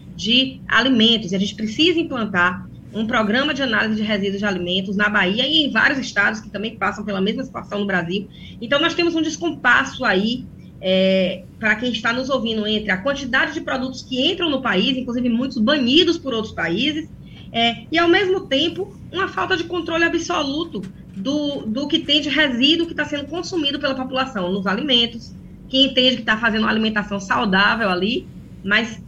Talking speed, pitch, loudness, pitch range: 185 wpm, 240 Hz, -19 LUFS, 205-290 Hz